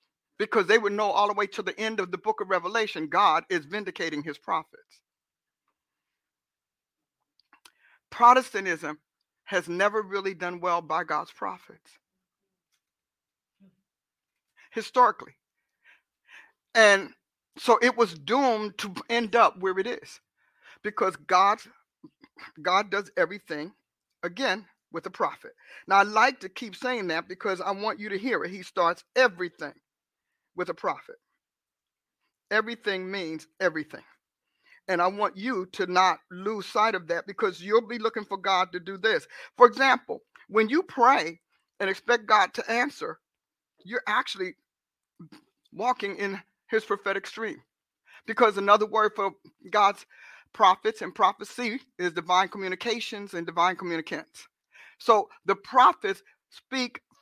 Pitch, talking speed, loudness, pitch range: 200 Hz, 135 wpm, -26 LUFS, 185-235 Hz